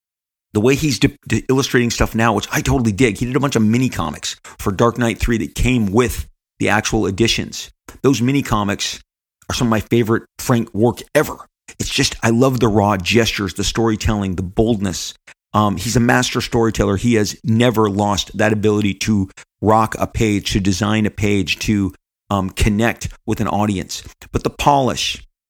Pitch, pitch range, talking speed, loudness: 110 Hz, 100-120 Hz, 185 wpm, -17 LUFS